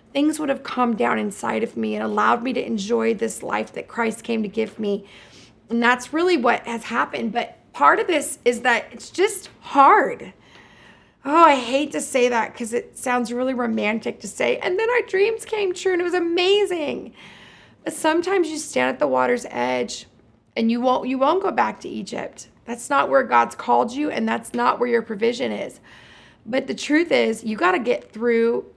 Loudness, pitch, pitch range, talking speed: -21 LUFS, 245 Hz, 225-305 Hz, 205 wpm